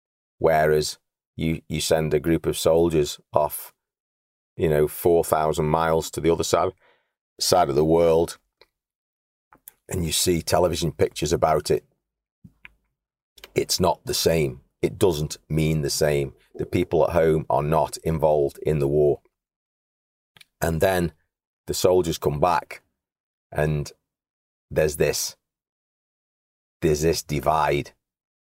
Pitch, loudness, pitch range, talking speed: 80 Hz, -23 LUFS, 75-80 Hz, 125 wpm